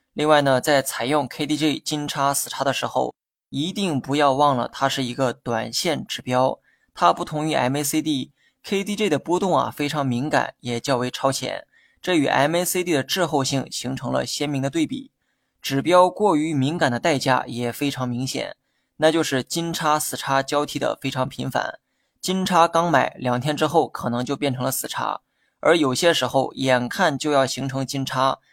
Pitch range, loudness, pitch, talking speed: 130-155 Hz, -22 LUFS, 140 Hz, 270 characters per minute